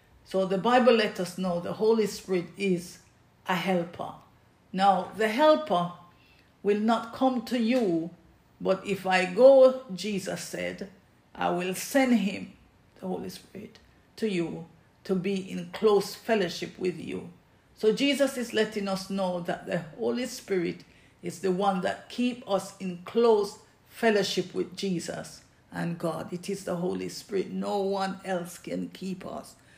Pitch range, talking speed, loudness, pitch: 180-220 Hz, 155 wpm, -28 LUFS, 195 Hz